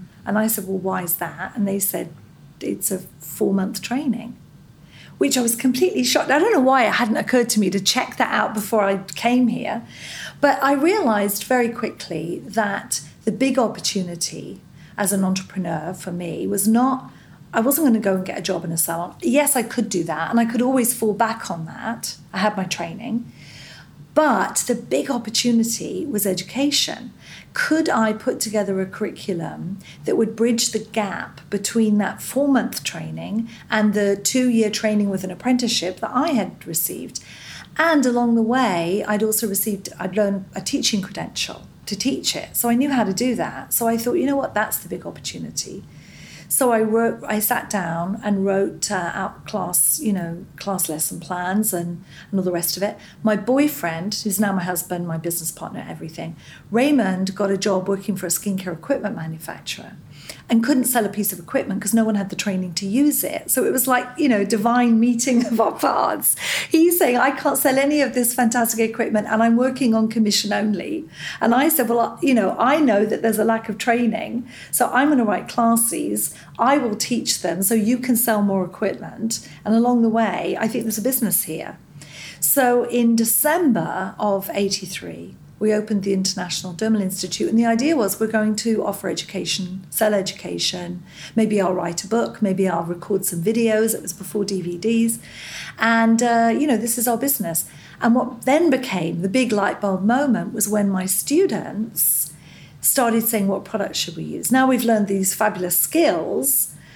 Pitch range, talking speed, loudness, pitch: 190-240 Hz, 190 wpm, -20 LUFS, 215 Hz